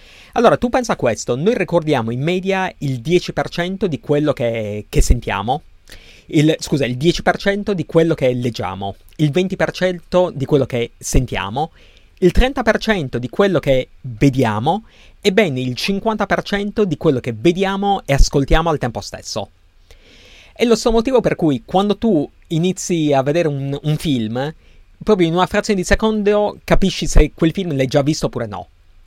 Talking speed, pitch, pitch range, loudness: 160 wpm, 160 Hz, 130-190 Hz, -18 LUFS